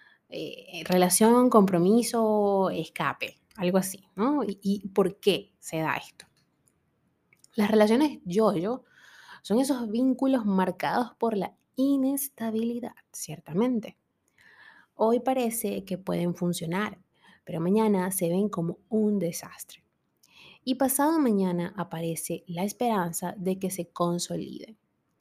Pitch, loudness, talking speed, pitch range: 205 Hz, -27 LUFS, 115 wpm, 180-240 Hz